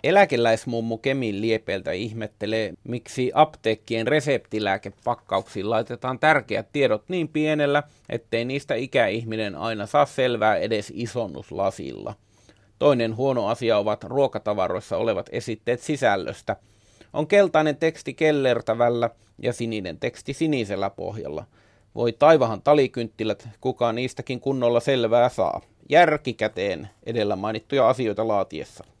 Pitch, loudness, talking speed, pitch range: 120 Hz, -23 LUFS, 105 wpm, 110-140 Hz